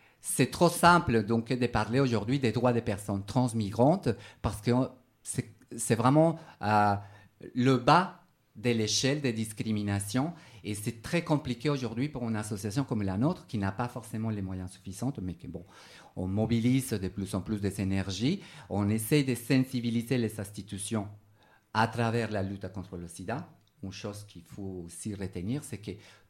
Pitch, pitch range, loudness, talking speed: 115 Hz, 100-130 Hz, -30 LUFS, 165 wpm